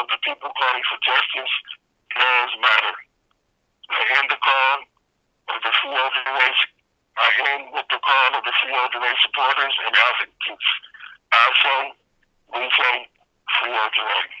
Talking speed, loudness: 150 wpm, -19 LUFS